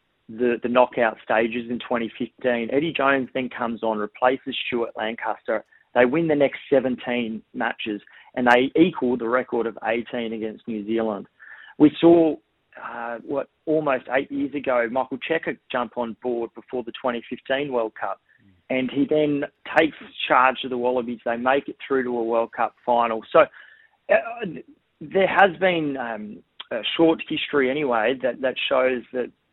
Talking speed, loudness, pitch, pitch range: 160 wpm, -23 LUFS, 125 Hz, 115-140 Hz